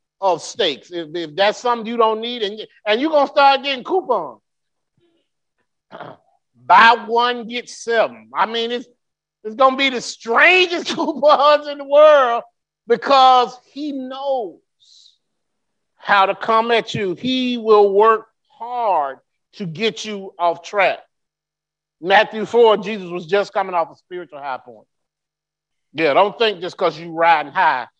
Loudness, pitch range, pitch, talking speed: -16 LUFS, 195-265 Hz, 225 Hz, 150 wpm